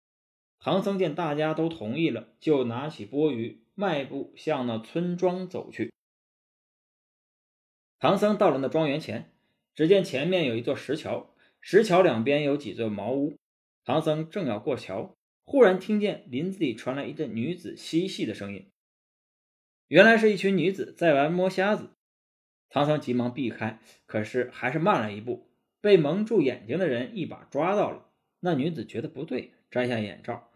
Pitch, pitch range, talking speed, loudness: 155 Hz, 120-185 Hz, 240 characters per minute, -26 LUFS